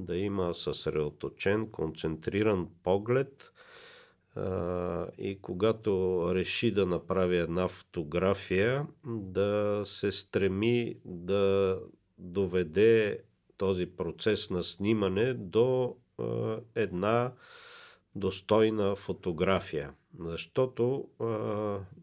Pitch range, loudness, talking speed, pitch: 90-110 Hz, -31 LUFS, 80 wpm, 100 Hz